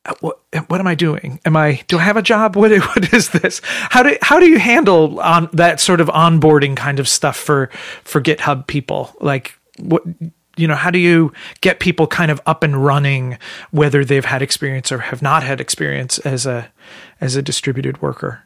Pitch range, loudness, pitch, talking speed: 140-175 Hz, -14 LUFS, 155 Hz, 205 wpm